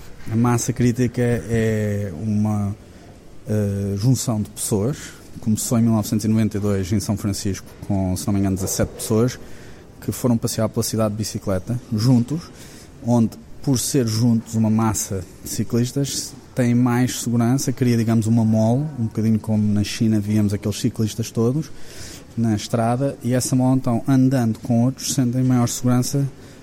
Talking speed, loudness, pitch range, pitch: 150 wpm, -21 LUFS, 105-125 Hz, 115 Hz